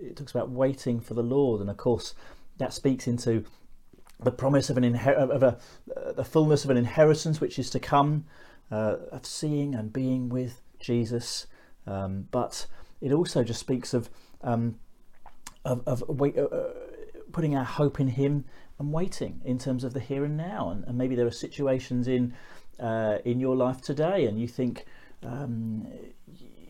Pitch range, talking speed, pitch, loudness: 120-145 Hz, 180 wpm, 130 Hz, -28 LUFS